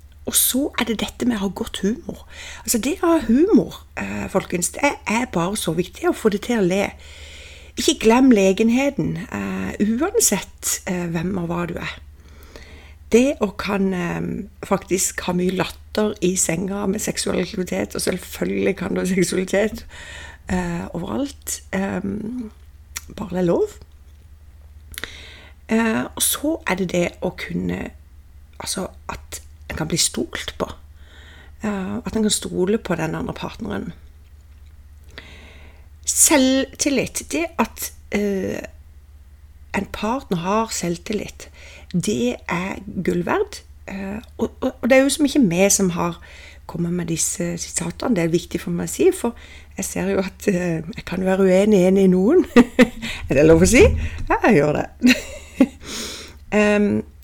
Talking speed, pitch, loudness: 150 wpm, 180 Hz, -20 LUFS